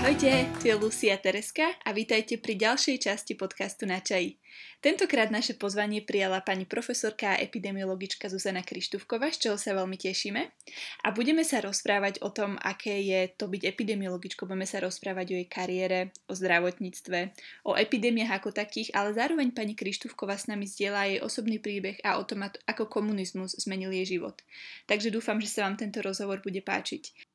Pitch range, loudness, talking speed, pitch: 190-220 Hz, -30 LUFS, 175 wpm, 200 Hz